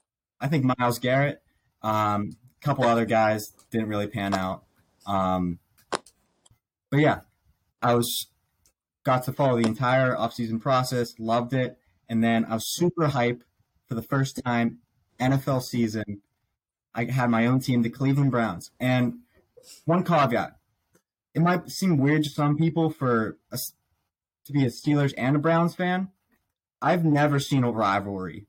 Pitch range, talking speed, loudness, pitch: 110-140 Hz, 150 wpm, -25 LUFS, 120 Hz